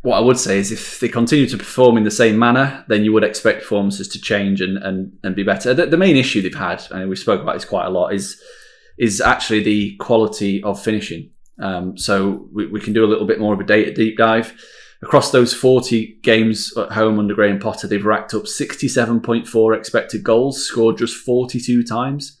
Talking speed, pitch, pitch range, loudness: 215 wpm, 110 Hz, 105-120 Hz, -17 LUFS